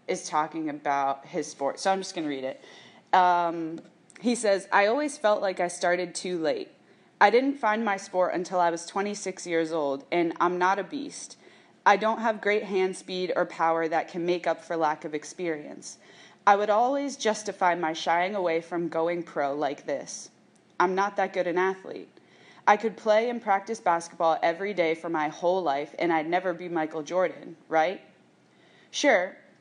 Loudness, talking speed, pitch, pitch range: -27 LUFS, 190 wpm, 175 Hz, 165-195 Hz